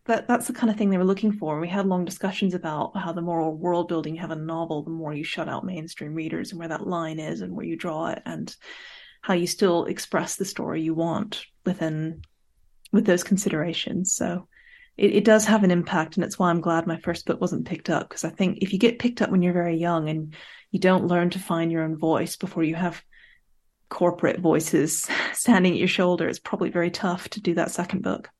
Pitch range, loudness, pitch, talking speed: 165-195 Hz, -25 LUFS, 175 Hz, 240 wpm